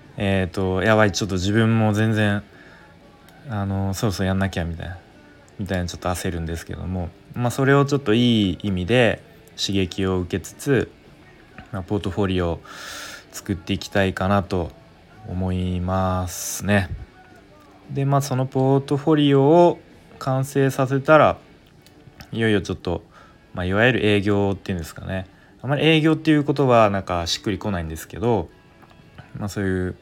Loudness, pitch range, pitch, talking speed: -21 LUFS, 95-115 Hz, 100 Hz, 340 characters per minute